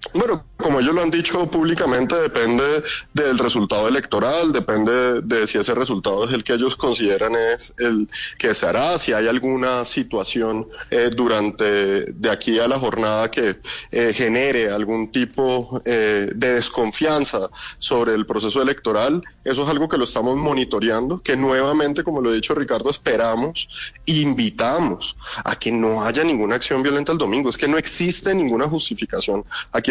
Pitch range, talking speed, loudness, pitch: 115-155 Hz, 165 wpm, -20 LUFS, 125 Hz